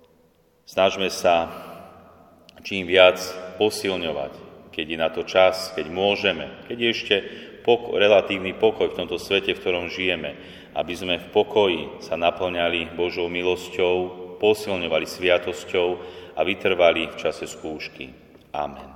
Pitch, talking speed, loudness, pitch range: 90 Hz, 125 wpm, -22 LUFS, 85-95 Hz